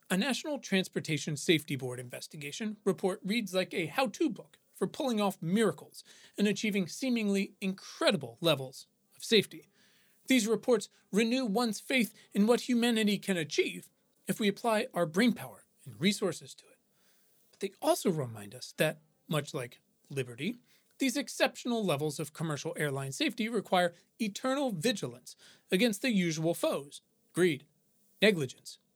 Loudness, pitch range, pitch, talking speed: -32 LUFS, 165-230 Hz, 200 Hz, 140 wpm